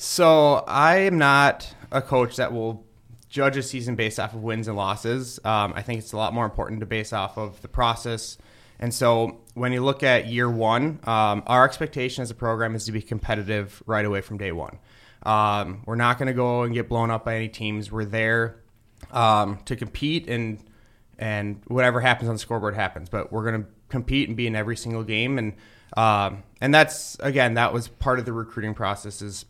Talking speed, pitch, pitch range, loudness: 210 wpm, 115 Hz, 110-125 Hz, -23 LUFS